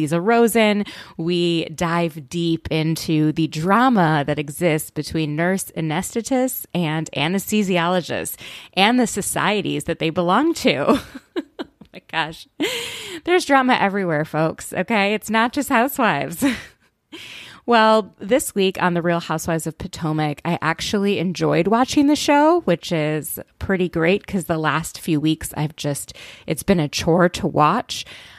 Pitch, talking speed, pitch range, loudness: 175 Hz, 140 wpm, 160-225 Hz, -20 LUFS